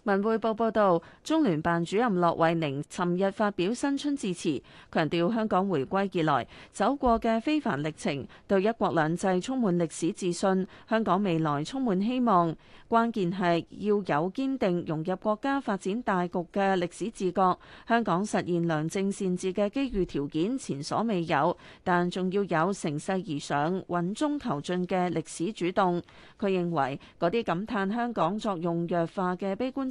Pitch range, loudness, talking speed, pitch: 170-215 Hz, -28 LUFS, 250 characters per minute, 185 Hz